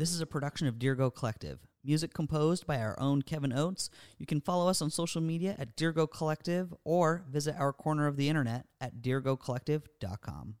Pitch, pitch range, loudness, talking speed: 150 Hz, 130-160 Hz, -33 LUFS, 185 wpm